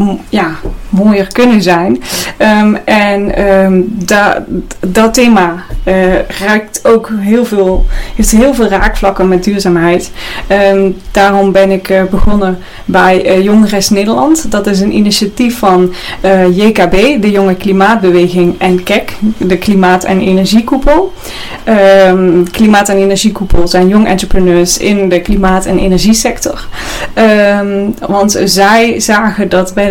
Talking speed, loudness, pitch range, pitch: 130 wpm, -8 LUFS, 185-210 Hz, 195 Hz